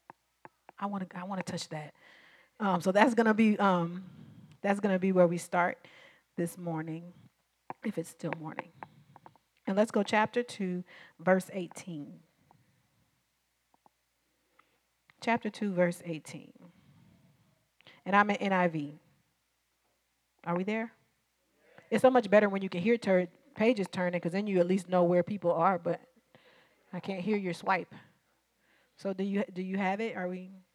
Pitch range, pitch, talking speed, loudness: 170-200 Hz, 185 Hz, 150 wpm, -31 LUFS